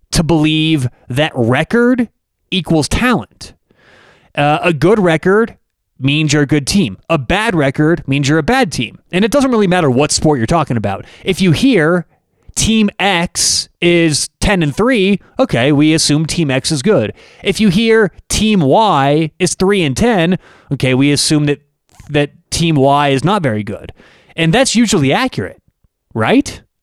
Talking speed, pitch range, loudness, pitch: 165 wpm, 145-195 Hz, -13 LUFS, 160 Hz